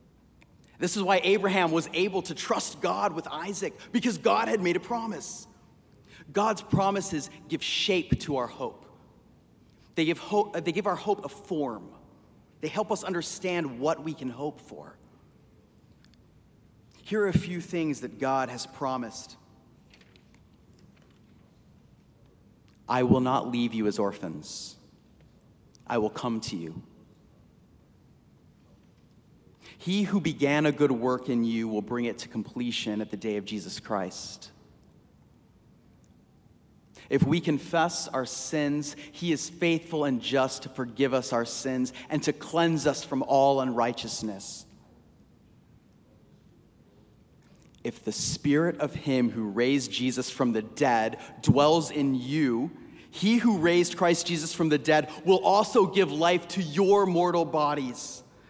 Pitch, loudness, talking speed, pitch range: 150 Hz, -28 LUFS, 135 wpm, 130-175 Hz